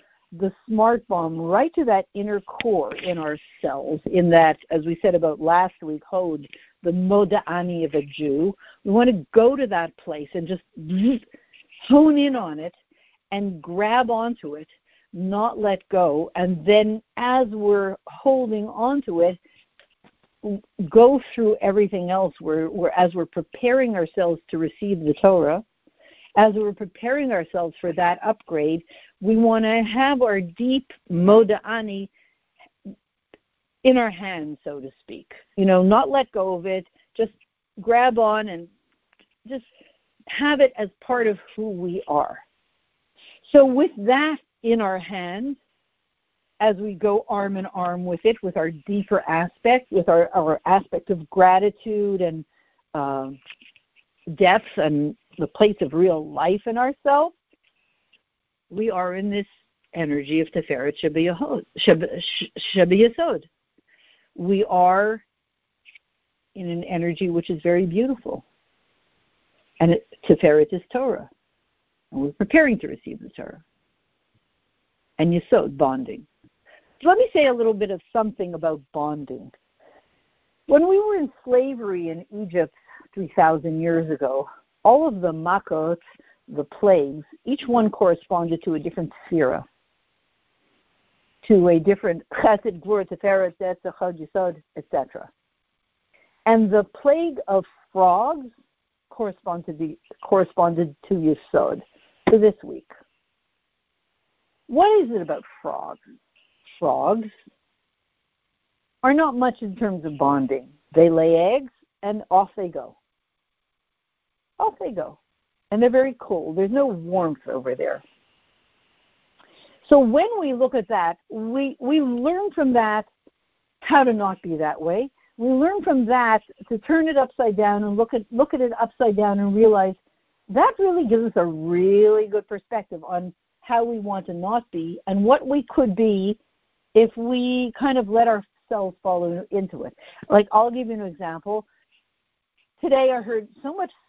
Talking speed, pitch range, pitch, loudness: 140 wpm, 175-240 Hz, 205 Hz, -21 LUFS